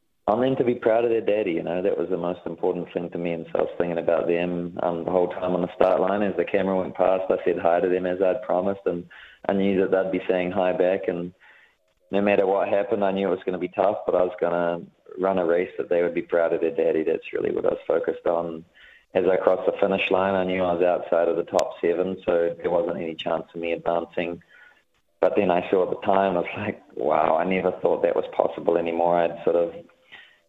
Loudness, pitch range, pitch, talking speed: -24 LUFS, 85-100 Hz, 90 Hz, 265 wpm